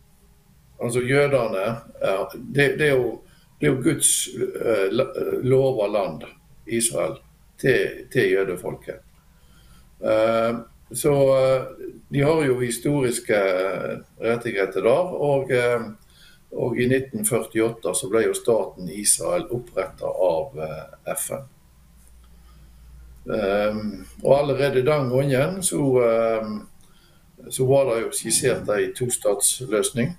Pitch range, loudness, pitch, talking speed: 110-140 Hz, -22 LUFS, 125 Hz, 105 wpm